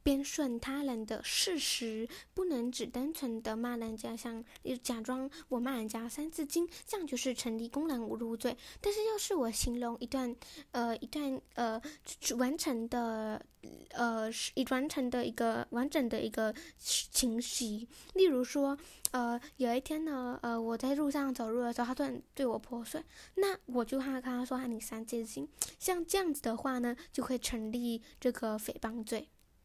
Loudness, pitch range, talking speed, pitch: -36 LUFS, 235-285 Hz, 240 characters per minute, 250 Hz